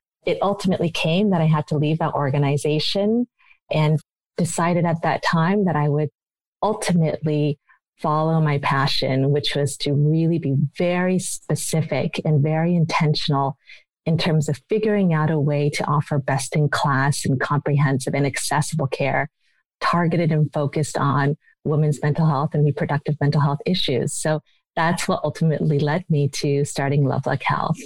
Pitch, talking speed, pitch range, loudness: 150 Hz, 155 wpm, 145-165 Hz, -21 LUFS